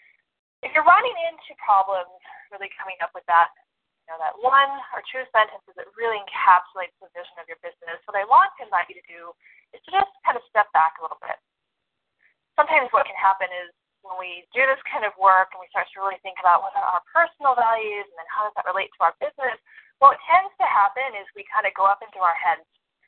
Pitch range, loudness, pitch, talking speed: 185-270 Hz, -21 LUFS, 200 Hz, 235 wpm